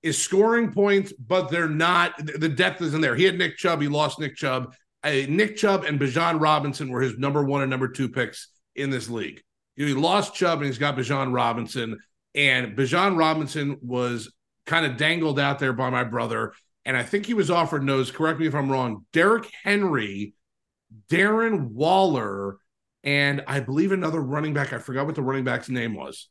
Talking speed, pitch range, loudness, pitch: 195 wpm, 130-170 Hz, -23 LUFS, 145 Hz